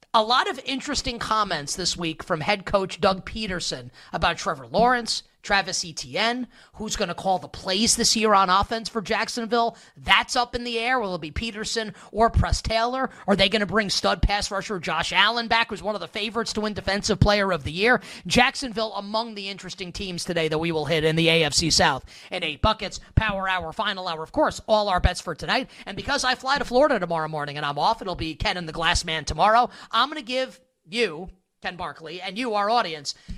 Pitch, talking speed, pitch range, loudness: 205 Hz, 220 wpm, 175-230 Hz, -23 LUFS